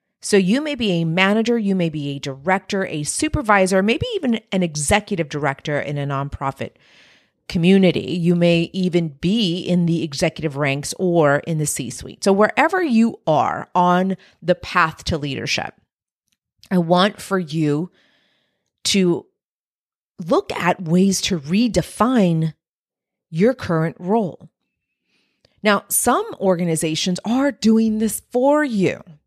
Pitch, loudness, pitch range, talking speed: 180 Hz, -19 LUFS, 160-205 Hz, 135 wpm